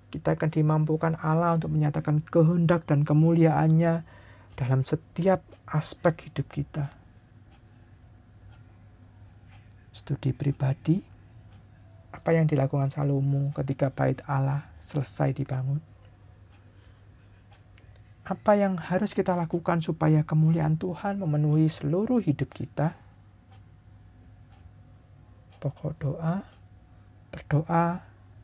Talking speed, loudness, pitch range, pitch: 85 wpm, -26 LUFS, 105-155 Hz, 140 Hz